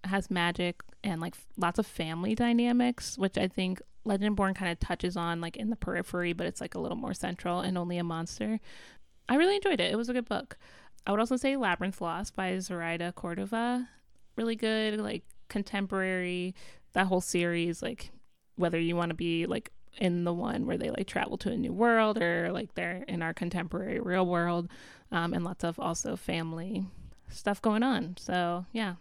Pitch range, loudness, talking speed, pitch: 175-220 Hz, -31 LUFS, 190 wpm, 185 Hz